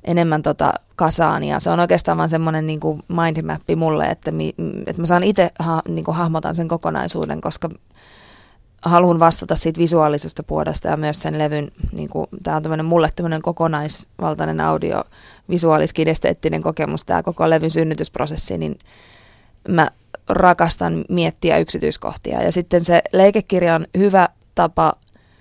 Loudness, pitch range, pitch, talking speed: -18 LUFS, 110-170 Hz, 160 Hz, 140 wpm